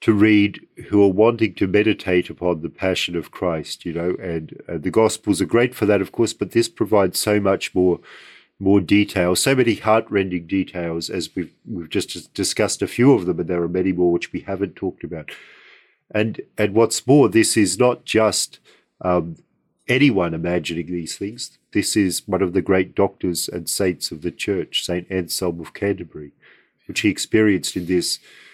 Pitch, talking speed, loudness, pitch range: 95 Hz, 190 wpm, -20 LUFS, 90-105 Hz